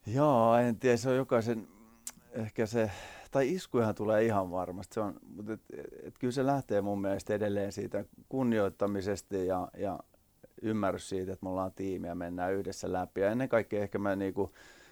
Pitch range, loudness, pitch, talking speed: 95-115 Hz, -33 LUFS, 105 Hz, 175 wpm